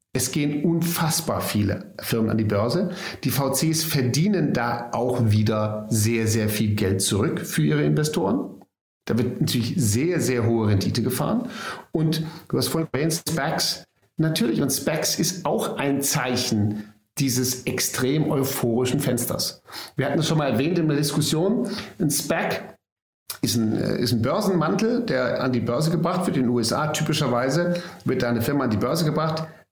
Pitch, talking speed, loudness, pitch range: 135 Hz, 165 wpm, -23 LUFS, 115-160 Hz